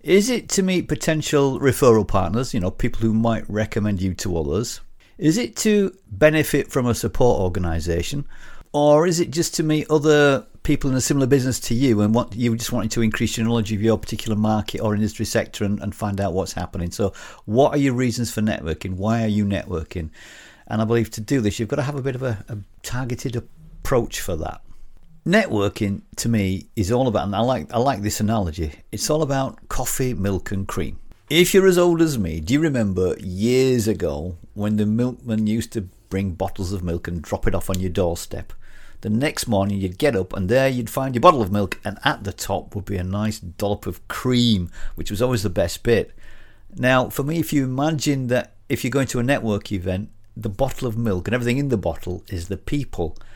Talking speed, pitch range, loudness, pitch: 220 wpm, 100-130 Hz, -21 LUFS, 110 Hz